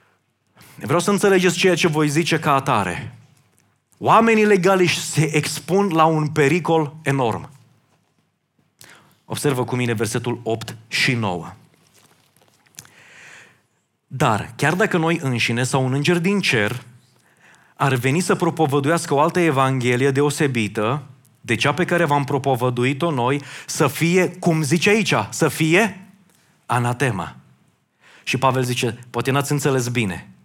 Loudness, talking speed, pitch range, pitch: -19 LUFS, 125 wpm, 125-165 Hz, 140 Hz